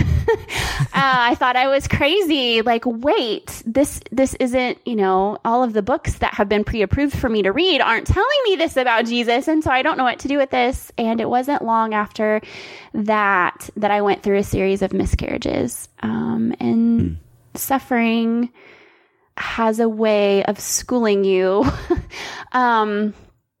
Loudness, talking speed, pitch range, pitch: -19 LUFS, 170 wpm, 205-265 Hz, 230 Hz